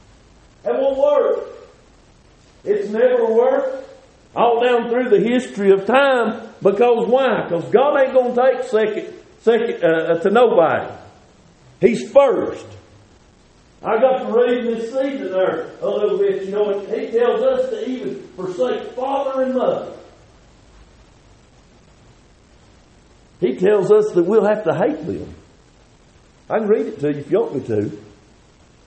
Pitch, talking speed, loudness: 245 Hz, 145 wpm, -18 LUFS